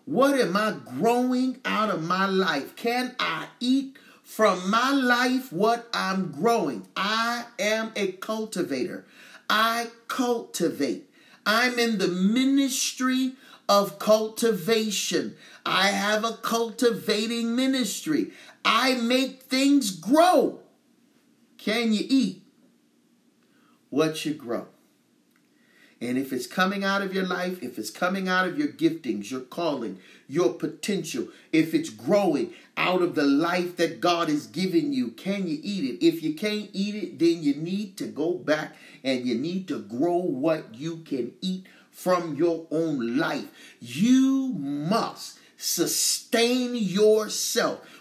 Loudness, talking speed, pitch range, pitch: -25 LUFS, 135 wpm, 180-255 Hz, 215 Hz